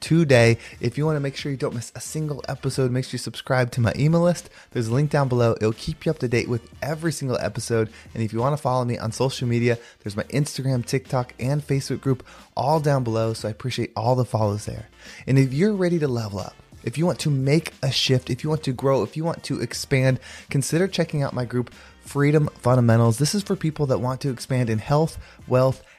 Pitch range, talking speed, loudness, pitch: 120-145 Hz, 240 wpm, -23 LUFS, 130 Hz